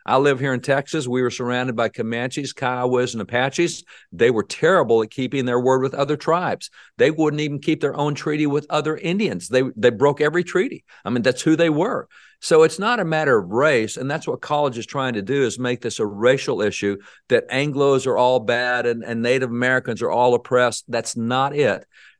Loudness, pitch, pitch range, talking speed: -20 LUFS, 130 Hz, 125-150 Hz, 215 wpm